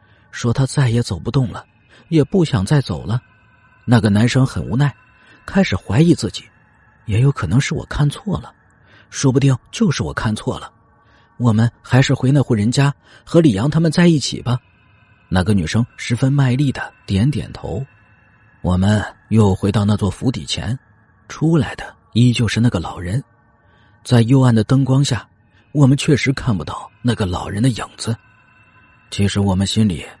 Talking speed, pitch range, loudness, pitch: 240 characters per minute, 105-135 Hz, -17 LUFS, 115 Hz